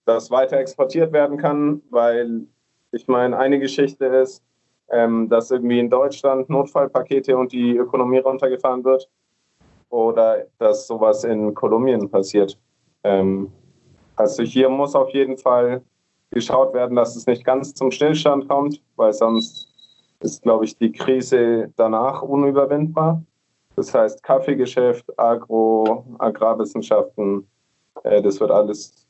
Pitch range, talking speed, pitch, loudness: 115-140 Hz, 130 wpm, 130 Hz, -19 LUFS